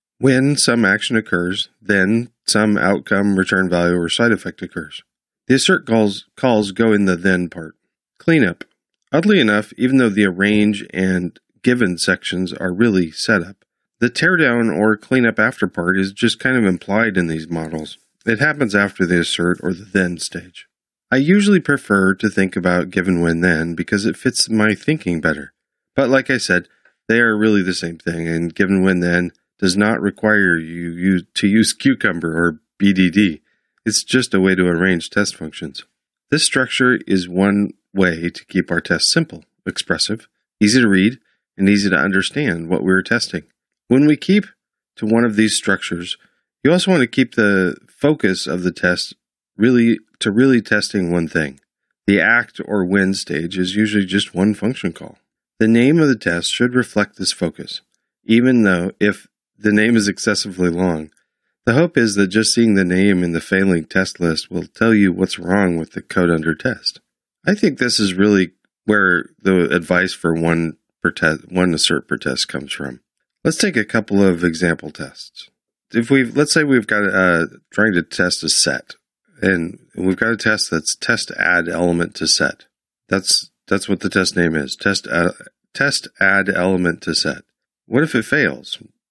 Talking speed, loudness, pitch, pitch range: 180 wpm, -17 LUFS, 95 Hz, 90-110 Hz